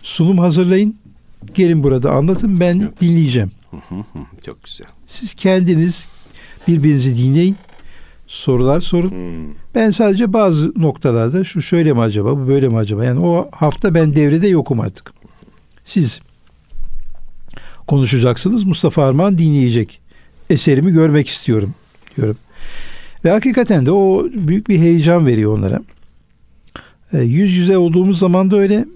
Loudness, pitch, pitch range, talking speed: -14 LUFS, 160 Hz, 120-185 Hz, 120 wpm